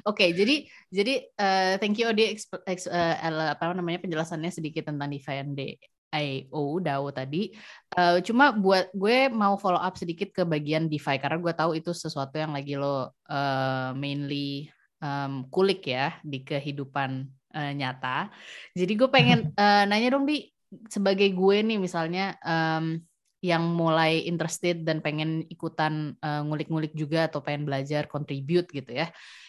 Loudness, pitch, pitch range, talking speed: -27 LUFS, 160 Hz, 145-190 Hz, 155 wpm